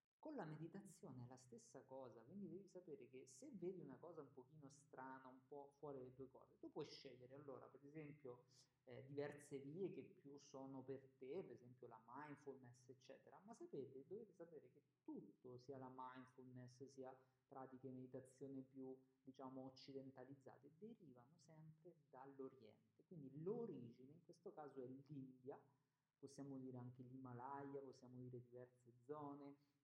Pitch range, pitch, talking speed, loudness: 130-145 Hz, 135 Hz, 155 wpm, -59 LUFS